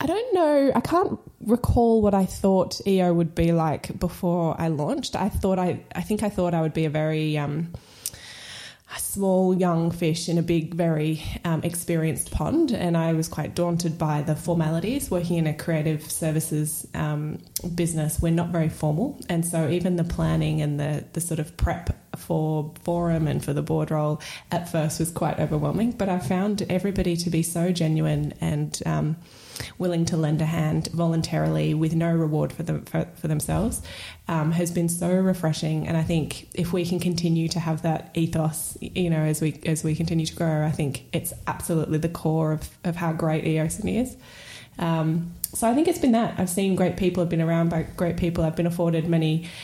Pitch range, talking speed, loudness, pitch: 155-175 Hz, 200 wpm, -25 LUFS, 165 Hz